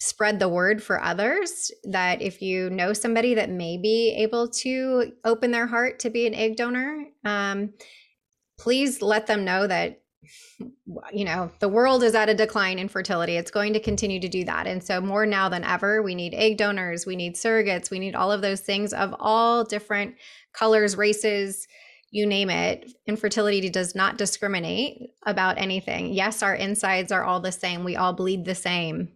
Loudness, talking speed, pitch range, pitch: -24 LUFS, 185 wpm, 190-225 Hz, 205 Hz